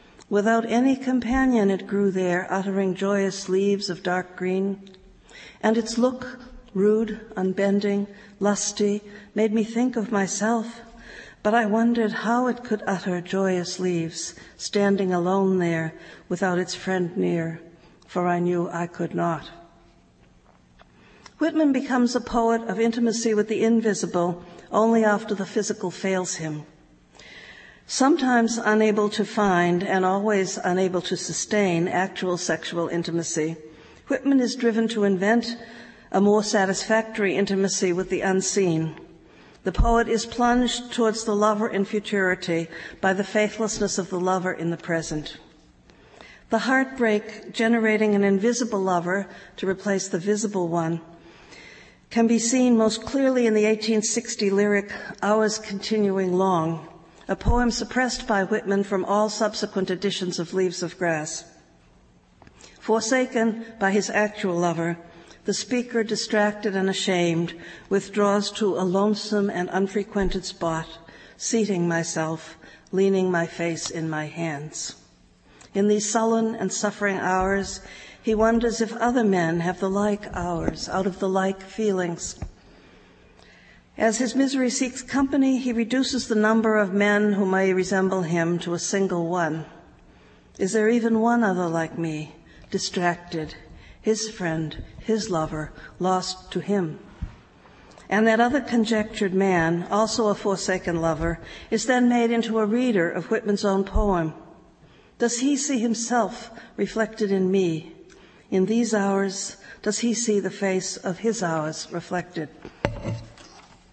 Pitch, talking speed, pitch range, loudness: 200 Hz, 135 wpm, 180-225 Hz, -24 LUFS